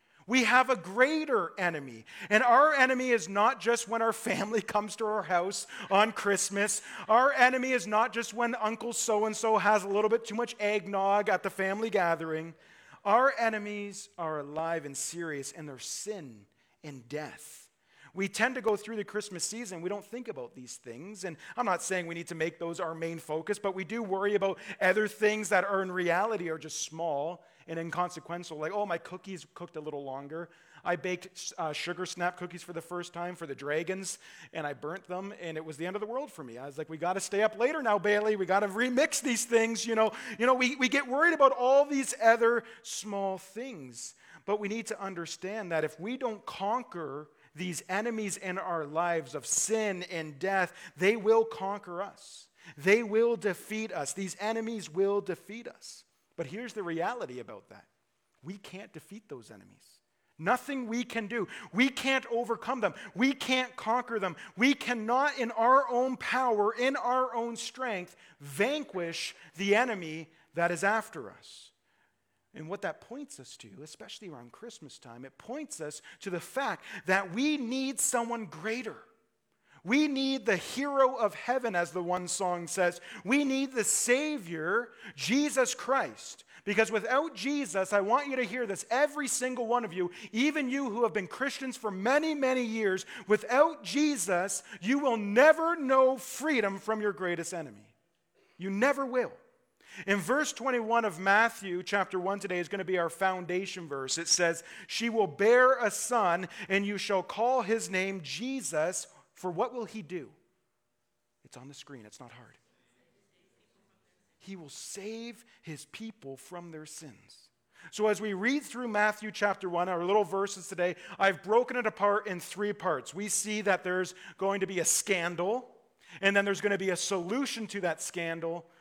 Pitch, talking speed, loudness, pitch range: 205 Hz, 185 wpm, -30 LUFS, 175-235 Hz